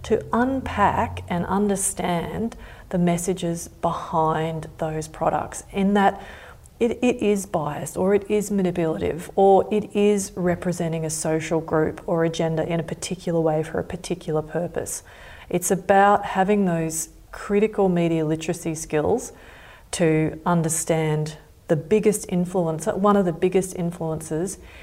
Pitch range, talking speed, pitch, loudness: 160-195 Hz, 135 wpm, 175 Hz, -23 LUFS